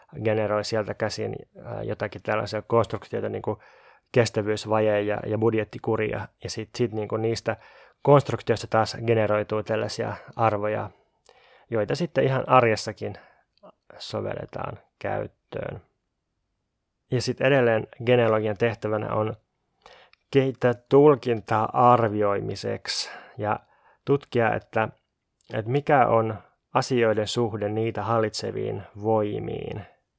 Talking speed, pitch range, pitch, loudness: 95 wpm, 105-120 Hz, 110 Hz, -25 LUFS